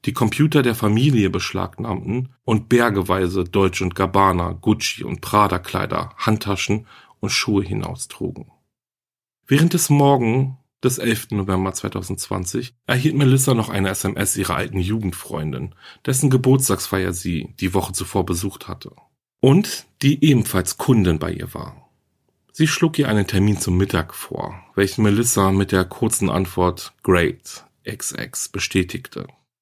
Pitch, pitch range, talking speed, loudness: 100 Hz, 95-125 Hz, 130 wpm, -20 LUFS